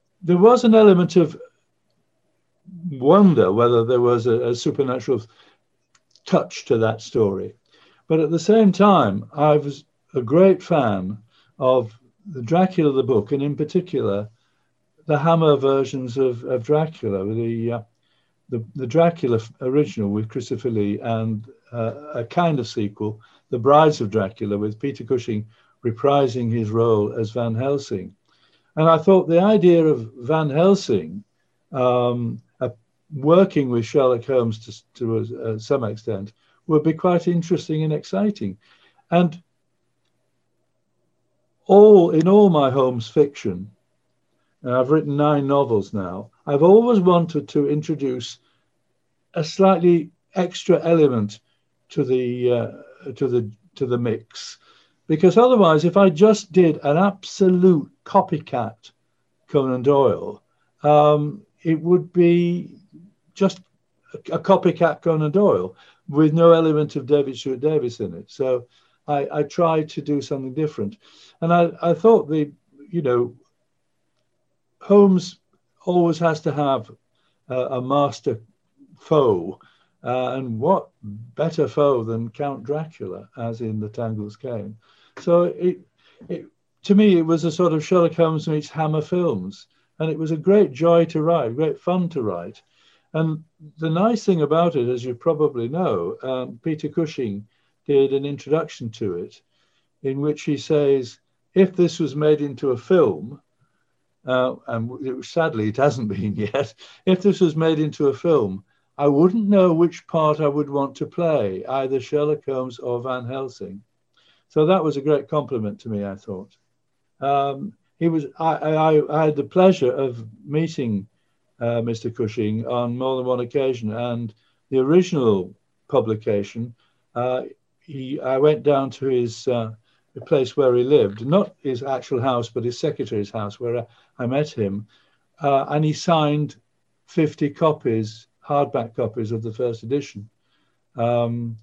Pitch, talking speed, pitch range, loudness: 145 Hz, 145 wpm, 120-165 Hz, -20 LUFS